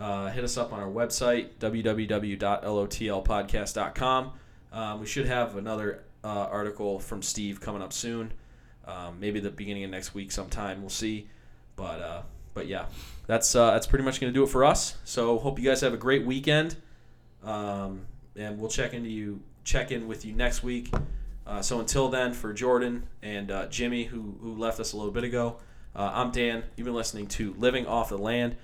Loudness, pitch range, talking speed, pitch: -29 LUFS, 100-120 Hz, 195 wpm, 110 Hz